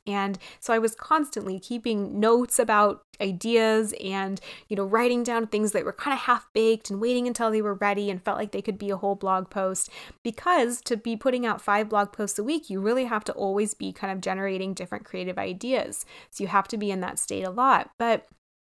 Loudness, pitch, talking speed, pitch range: -26 LUFS, 215 Hz, 225 wpm, 195-235 Hz